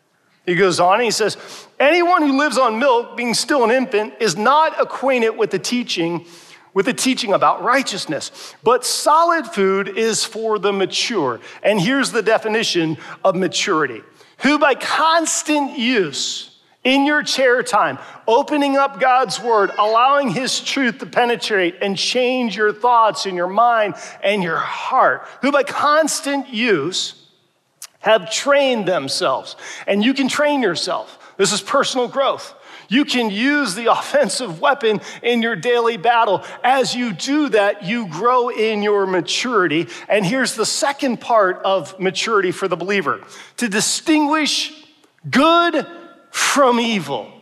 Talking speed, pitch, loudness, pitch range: 145 wpm, 240 Hz, -17 LUFS, 205-280 Hz